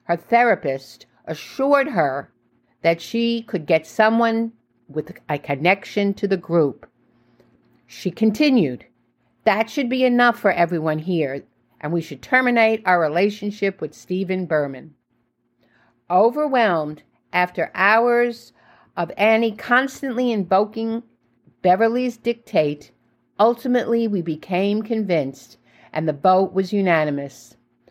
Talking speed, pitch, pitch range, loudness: 110 wpm, 185 Hz, 150-230 Hz, -20 LUFS